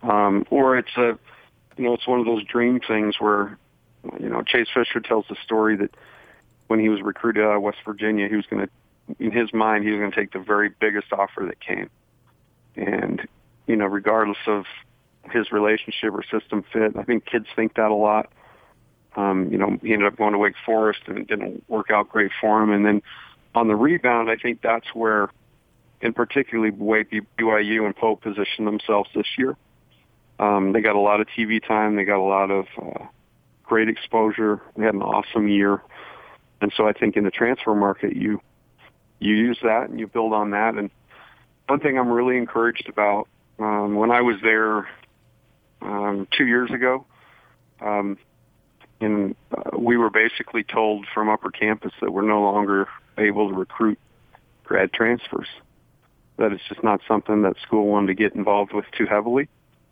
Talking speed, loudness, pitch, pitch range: 185 wpm, -22 LUFS, 110 Hz, 105-115 Hz